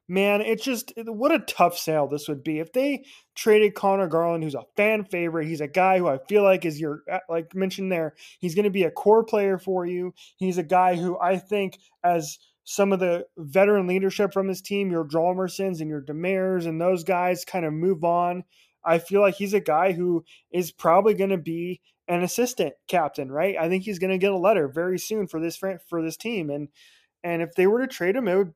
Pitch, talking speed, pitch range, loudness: 185 Hz, 225 wpm, 170-195 Hz, -24 LUFS